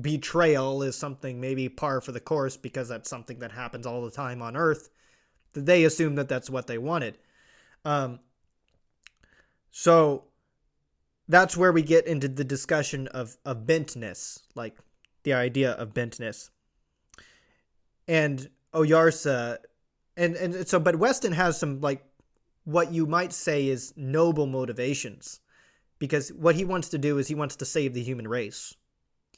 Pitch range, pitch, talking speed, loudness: 125-160 Hz, 140 Hz, 150 wpm, -26 LUFS